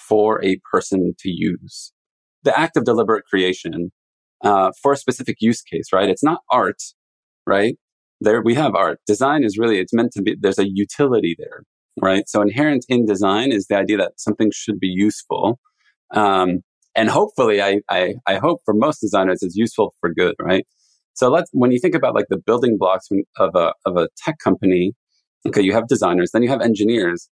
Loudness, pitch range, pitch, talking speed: -18 LUFS, 95-115 Hz, 105 Hz, 195 wpm